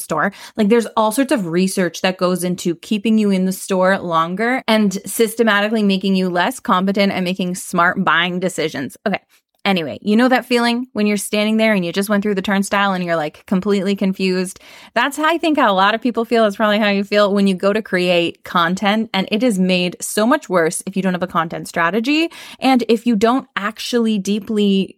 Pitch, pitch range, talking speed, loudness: 200 Hz, 185-225 Hz, 215 wpm, -17 LUFS